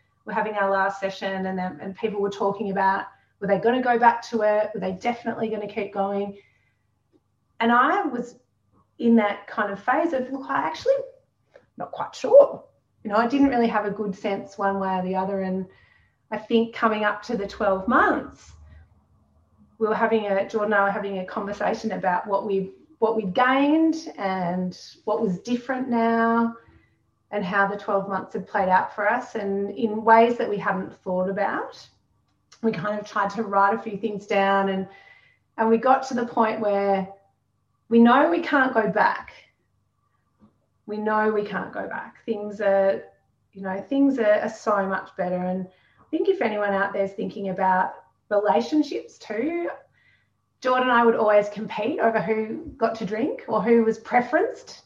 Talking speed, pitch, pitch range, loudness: 185 wpm, 210 Hz, 195-230 Hz, -23 LUFS